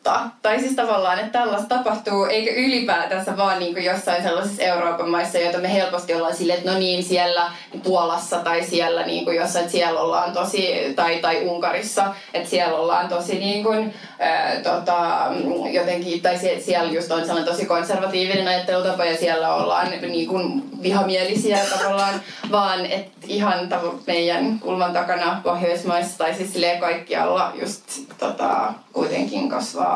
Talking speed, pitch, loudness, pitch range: 150 wpm, 180 Hz, -21 LUFS, 175-195 Hz